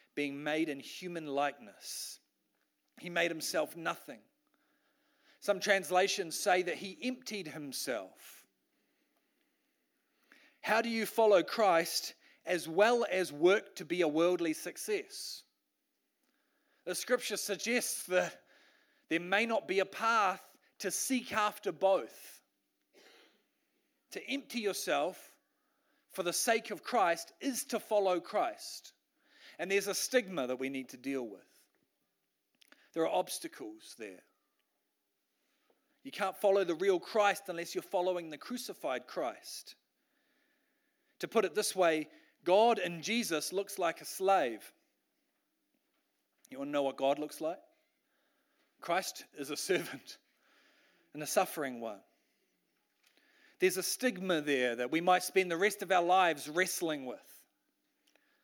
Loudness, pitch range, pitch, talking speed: -33 LUFS, 175-275 Hz, 200 Hz, 130 wpm